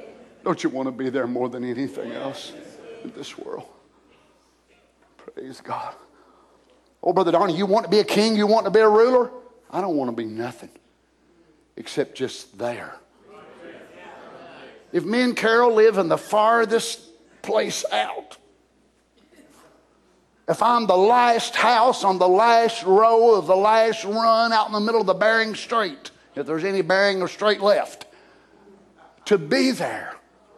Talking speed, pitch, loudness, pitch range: 155 wpm, 210 Hz, -20 LUFS, 180-230 Hz